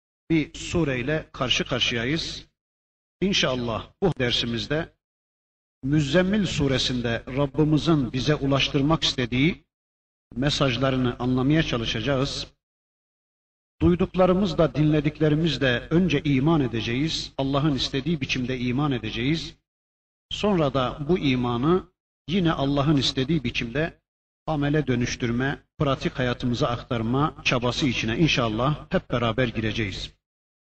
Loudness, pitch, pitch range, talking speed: -24 LUFS, 135 Hz, 120-155 Hz, 90 wpm